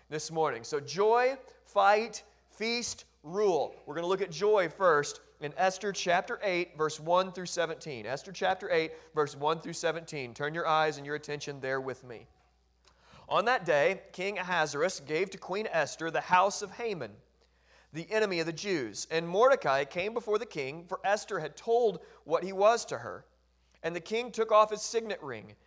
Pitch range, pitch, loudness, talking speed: 150-205 Hz, 175 Hz, -31 LUFS, 185 wpm